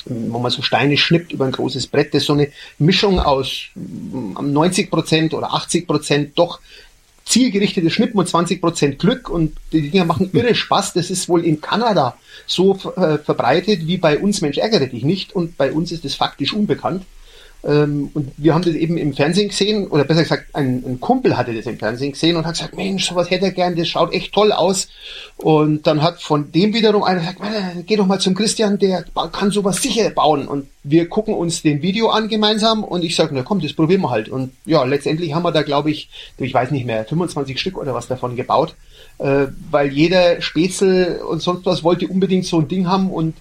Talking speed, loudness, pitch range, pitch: 205 wpm, -17 LUFS, 145-190 Hz, 170 Hz